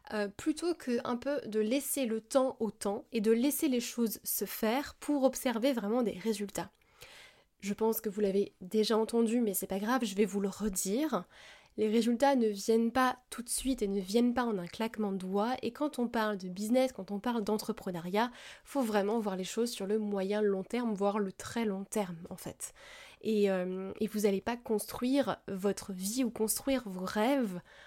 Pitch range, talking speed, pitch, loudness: 200-245 Hz, 210 wpm, 220 Hz, -33 LUFS